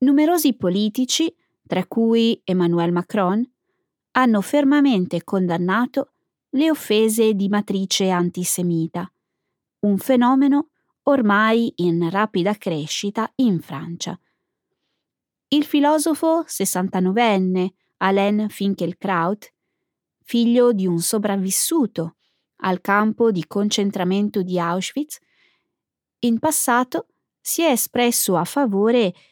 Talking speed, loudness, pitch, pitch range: 90 wpm, -20 LUFS, 210 Hz, 185-255 Hz